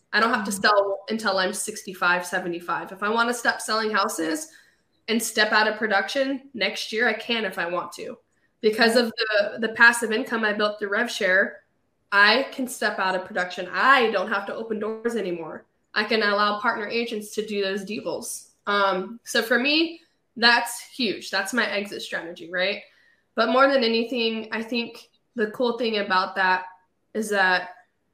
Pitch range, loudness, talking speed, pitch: 195-235 Hz, -23 LUFS, 180 wpm, 215 Hz